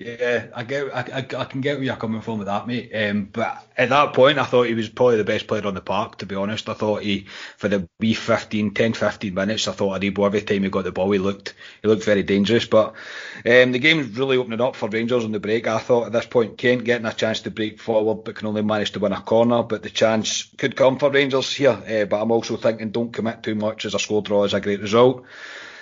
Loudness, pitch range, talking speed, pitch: -21 LUFS, 105-120 Hz, 270 wpm, 110 Hz